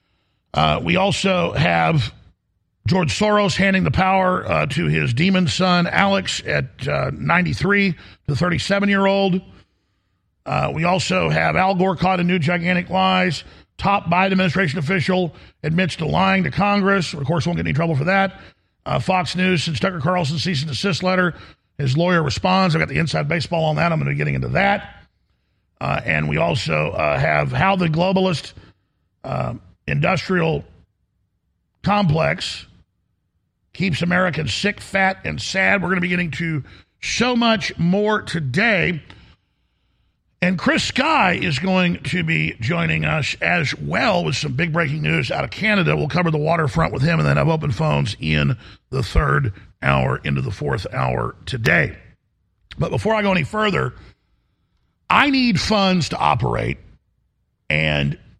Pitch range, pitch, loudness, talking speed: 130-185 Hz, 170 Hz, -19 LUFS, 160 wpm